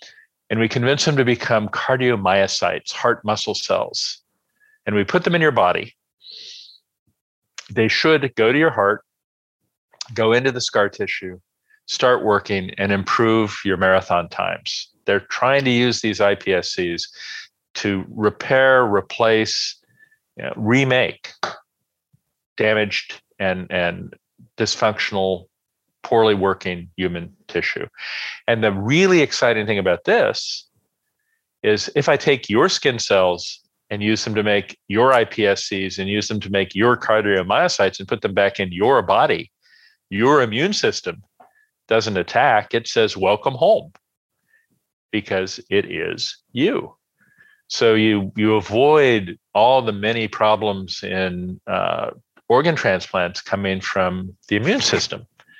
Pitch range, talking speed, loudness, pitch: 95-125 Hz, 130 wpm, -19 LUFS, 110 Hz